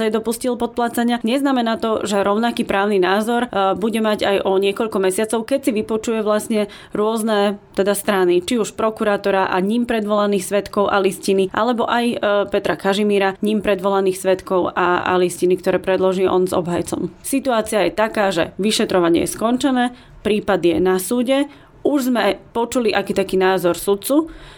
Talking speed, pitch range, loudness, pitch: 155 wpm, 190-230 Hz, -18 LUFS, 205 Hz